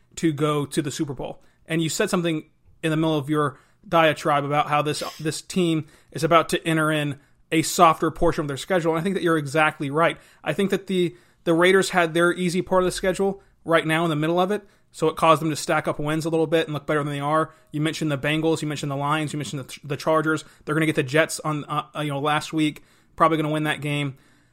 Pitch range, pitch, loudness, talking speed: 150-165 Hz, 160 Hz, -23 LUFS, 260 wpm